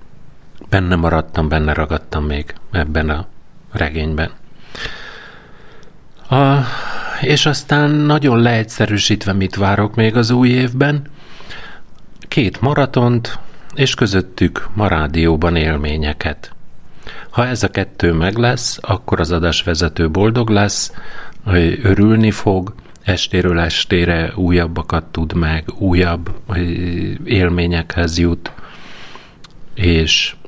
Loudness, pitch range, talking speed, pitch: -16 LUFS, 85-115 Hz, 100 wpm, 90 Hz